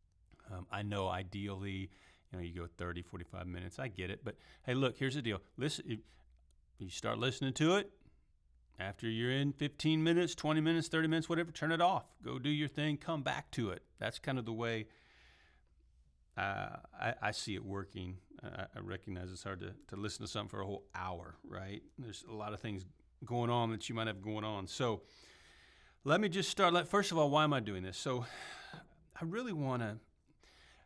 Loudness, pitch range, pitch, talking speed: -38 LUFS, 90-140 Hz, 105 Hz, 205 wpm